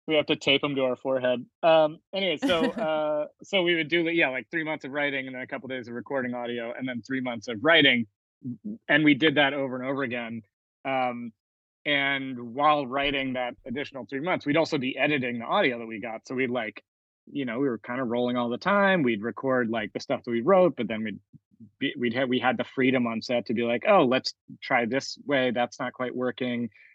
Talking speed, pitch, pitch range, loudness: 240 wpm, 130 Hz, 120-150 Hz, -26 LUFS